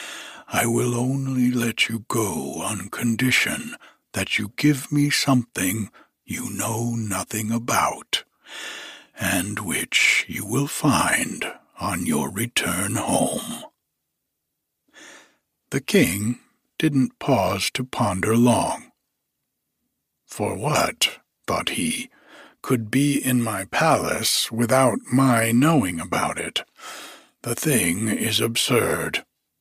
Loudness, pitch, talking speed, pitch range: -22 LUFS, 120 Hz, 105 wpm, 115-135 Hz